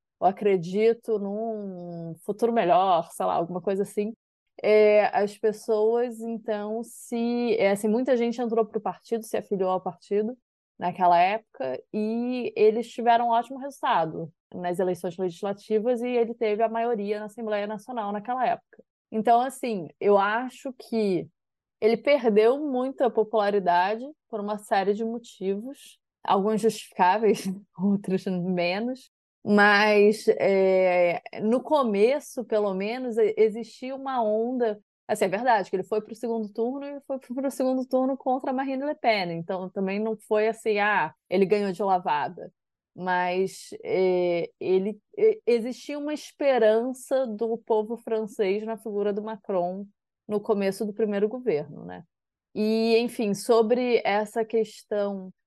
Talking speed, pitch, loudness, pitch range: 140 wpm, 220 Hz, -25 LUFS, 200-235 Hz